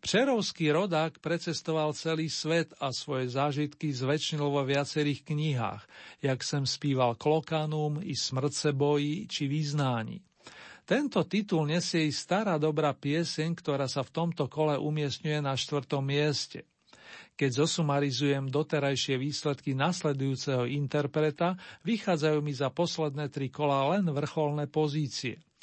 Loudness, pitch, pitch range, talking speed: -30 LUFS, 150 Hz, 140-160 Hz, 120 wpm